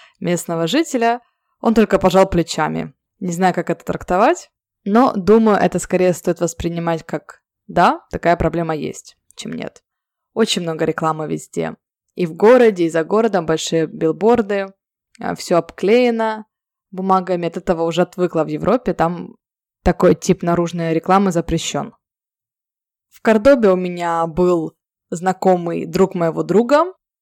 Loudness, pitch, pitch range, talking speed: -17 LUFS, 180 Hz, 170-215 Hz, 130 wpm